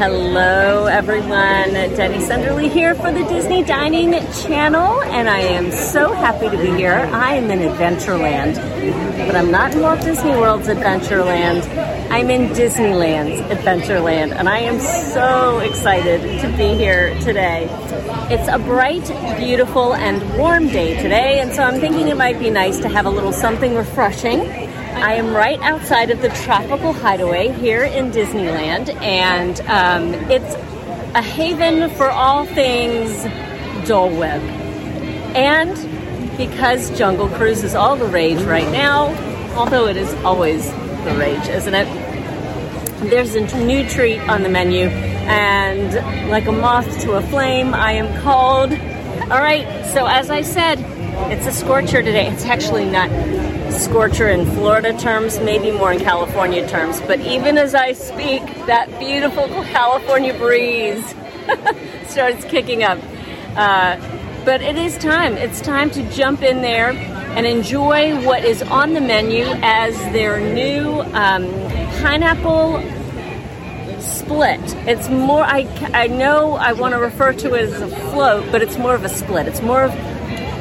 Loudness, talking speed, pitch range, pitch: -16 LUFS, 150 wpm, 195-275 Hz, 240 Hz